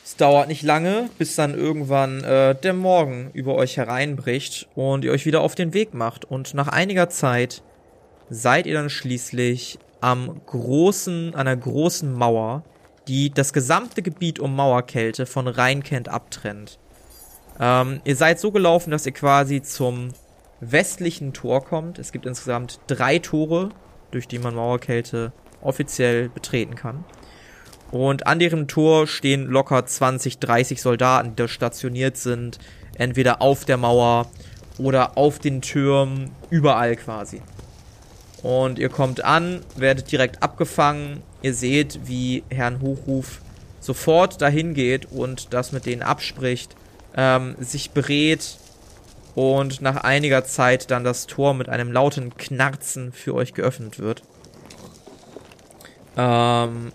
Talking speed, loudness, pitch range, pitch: 135 wpm, -21 LUFS, 125-145 Hz, 130 Hz